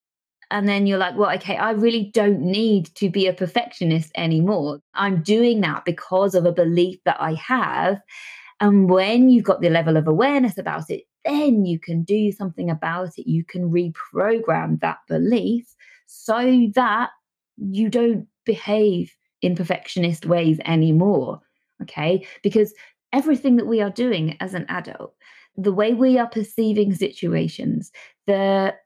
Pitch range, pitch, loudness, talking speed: 175-230 Hz, 200 Hz, -20 LUFS, 150 wpm